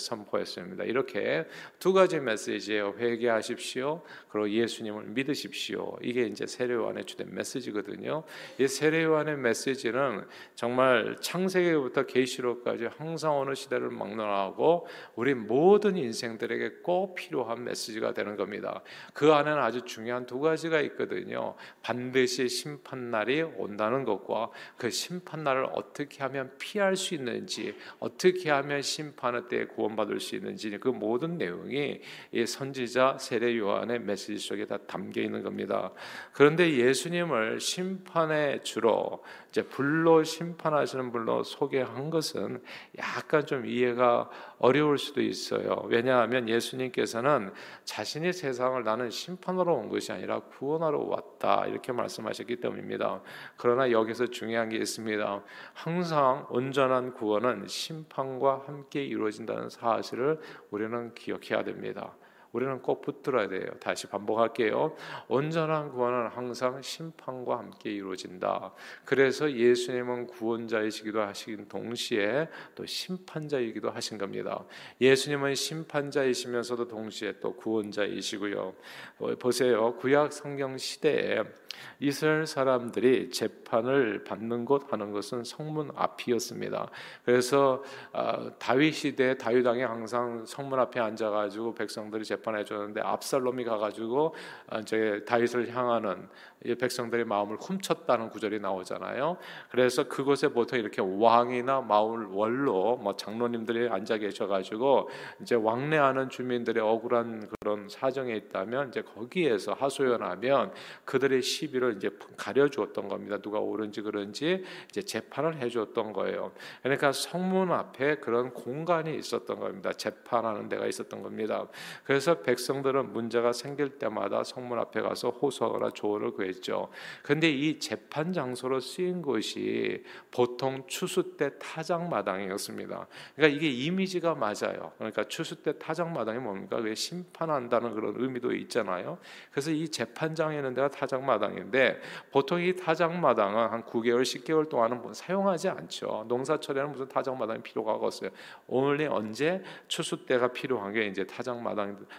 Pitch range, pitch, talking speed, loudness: 115-150 Hz, 130 Hz, 330 characters per minute, -30 LUFS